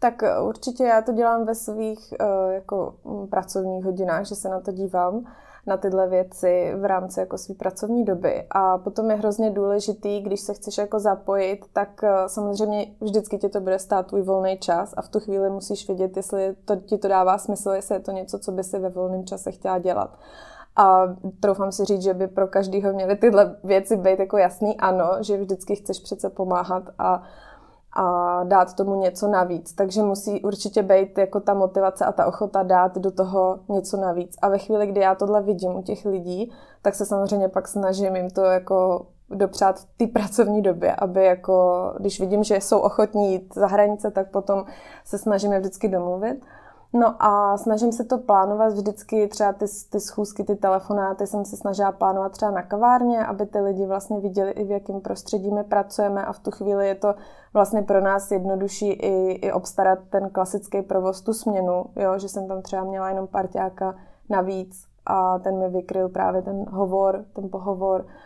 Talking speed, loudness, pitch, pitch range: 190 wpm, -23 LUFS, 195 Hz, 190-205 Hz